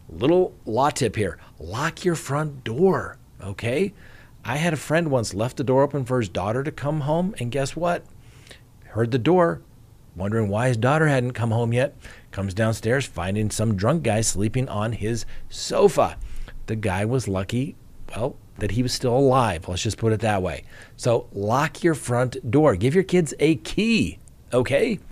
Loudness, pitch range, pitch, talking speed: -23 LUFS, 110-145 Hz, 125 Hz, 180 wpm